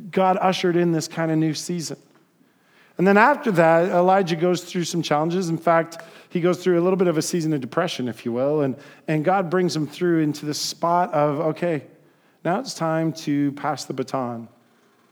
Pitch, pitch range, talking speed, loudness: 165 Hz, 150-180 Hz, 200 wpm, -22 LUFS